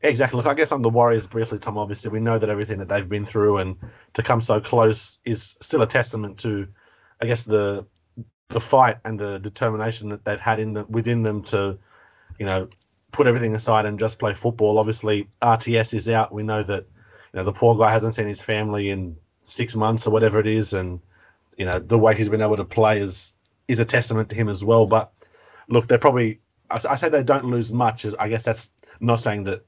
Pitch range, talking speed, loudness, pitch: 105-115 Hz, 225 wpm, -22 LUFS, 110 Hz